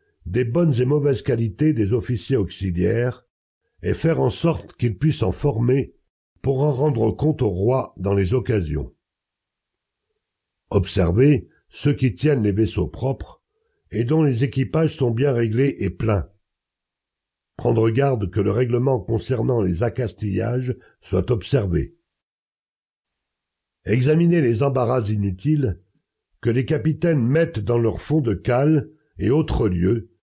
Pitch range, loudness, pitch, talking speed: 105-145 Hz, -21 LUFS, 125 Hz, 135 wpm